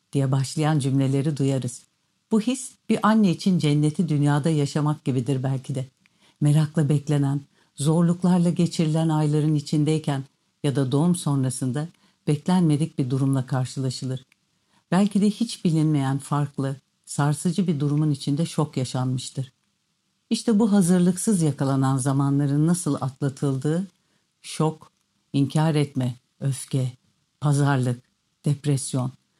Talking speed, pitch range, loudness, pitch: 110 wpm, 135-170 Hz, -23 LUFS, 150 Hz